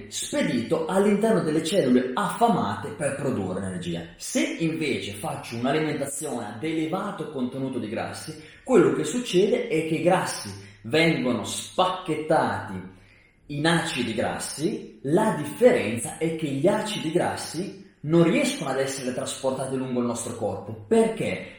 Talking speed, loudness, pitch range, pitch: 130 wpm, -25 LUFS, 120-170 Hz, 150 Hz